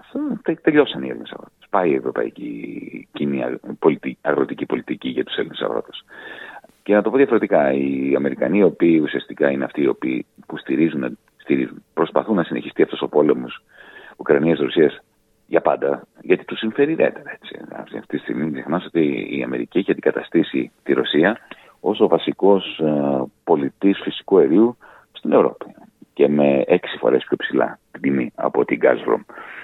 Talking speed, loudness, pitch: 150 wpm, -20 LUFS, 110 Hz